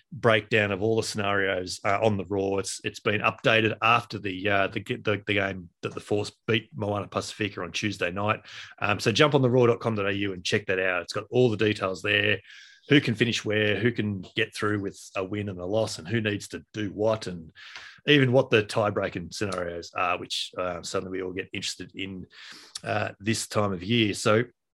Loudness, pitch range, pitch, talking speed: -26 LUFS, 95-110 Hz, 105 Hz, 210 wpm